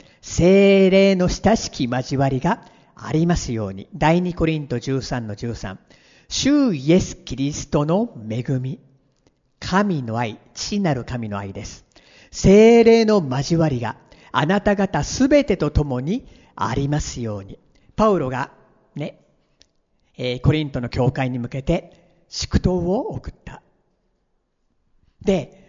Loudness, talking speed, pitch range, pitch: -20 LUFS, 215 characters per minute, 125-185 Hz, 145 Hz